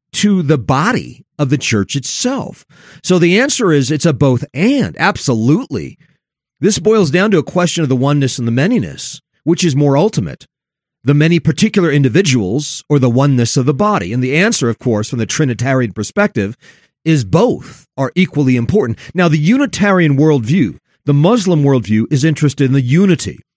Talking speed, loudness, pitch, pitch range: 175 wpm, -13 LUFS, 150 Hz, 135-180 Hz